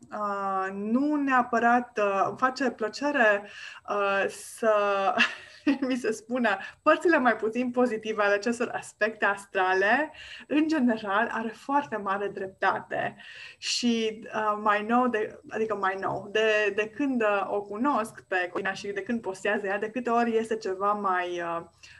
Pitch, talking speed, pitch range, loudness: 215 Hz, 145 wpm, 200-240 Hz, -27 LUFS